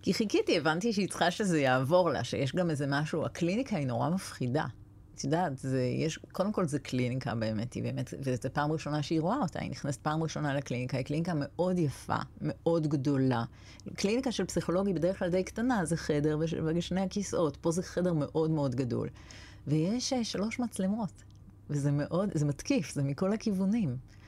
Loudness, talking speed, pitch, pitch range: -31 LUFS, 175 wpm, 155 Hz, 130-185 Hz